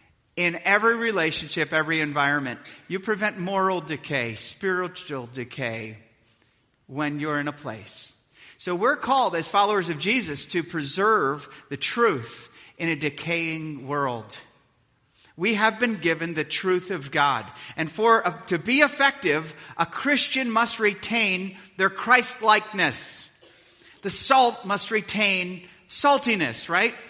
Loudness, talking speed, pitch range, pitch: -23 LUFS, 130 wpm, 145-215 Hz, 170 Hz